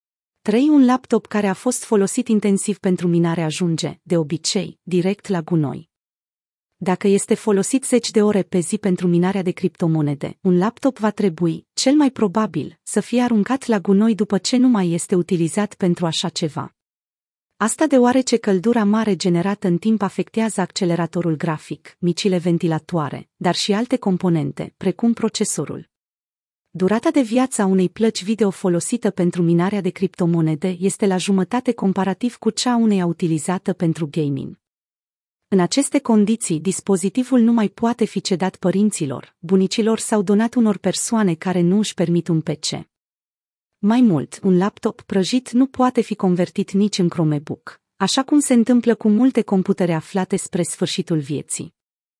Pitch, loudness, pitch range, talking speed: 195 Hz, -19 LUFS, 175-220 Hz, 155 wpm